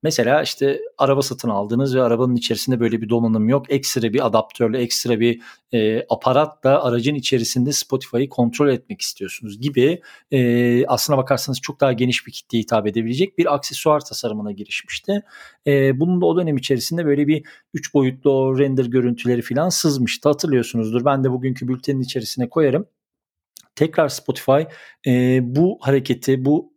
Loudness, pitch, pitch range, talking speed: -19 LUFS, 130 Hz, 120-145 Hz, 150 wpm